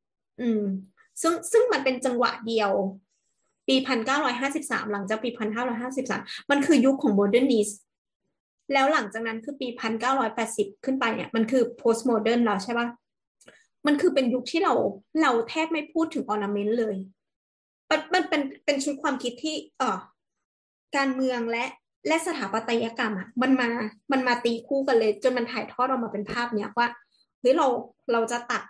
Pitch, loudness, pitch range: 245 Hz, -26 LUFS, 225-280 Hz